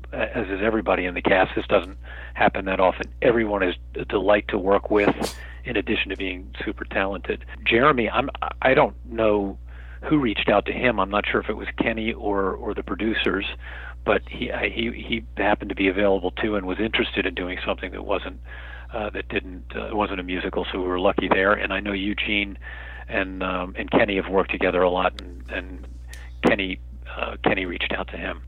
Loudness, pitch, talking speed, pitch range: -23 LUFS, 95 Hz, 200 wpm, 60-105 Hz